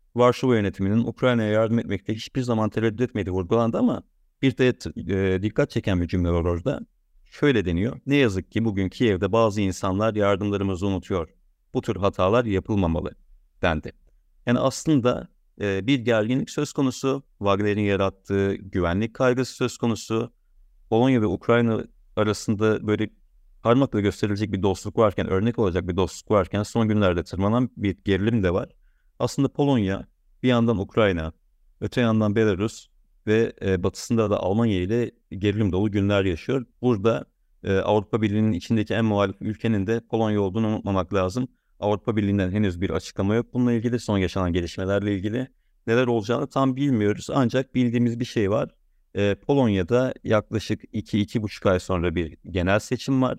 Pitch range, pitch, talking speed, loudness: 95-120 Hz, 105 Hz, 145 wpm, -24 LUFS